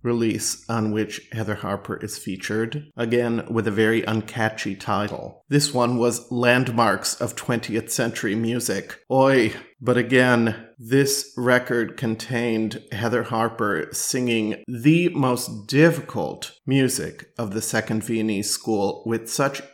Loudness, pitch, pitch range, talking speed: -23 LUFS, 115 Hz, 110-125 Hz, 125 wpm